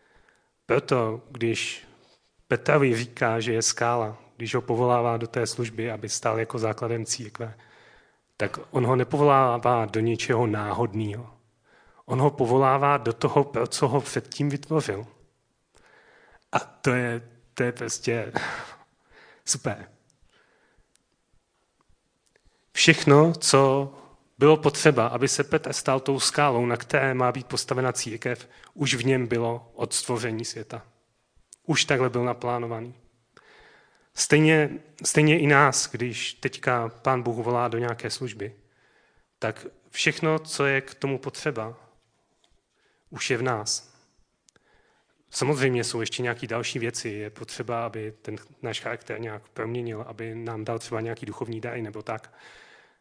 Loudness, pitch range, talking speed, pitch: -25 LUFS, 115-135 Hz, 130 wpm, 120 Hz